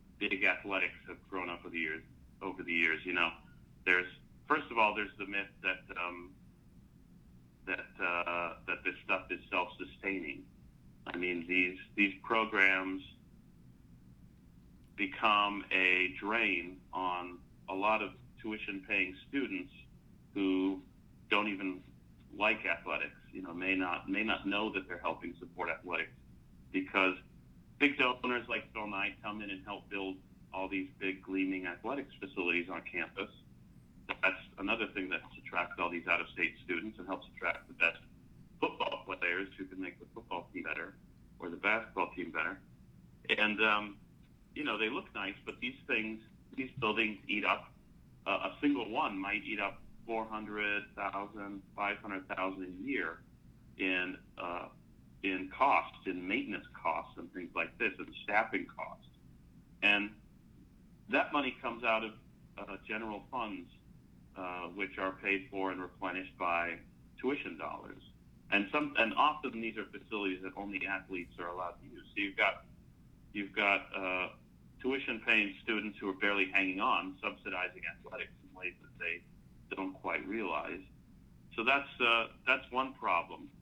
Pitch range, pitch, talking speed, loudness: 90-105 Hz, 95 Hz, 150 wpm, -35 LUFS